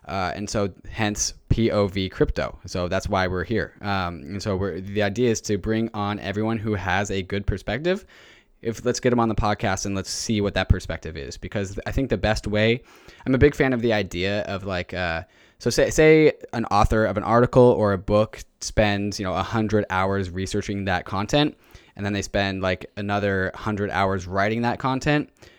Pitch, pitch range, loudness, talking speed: 100 Hz, 95-110 Hz, -23 LUFS, 205 wpm